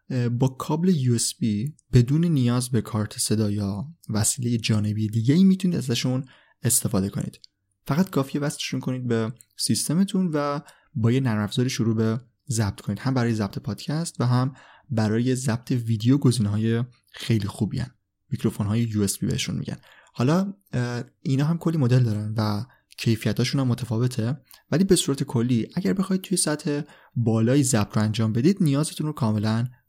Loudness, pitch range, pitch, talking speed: -24 LUFS, 110-145 Hz, 125 Hz, 160 wpm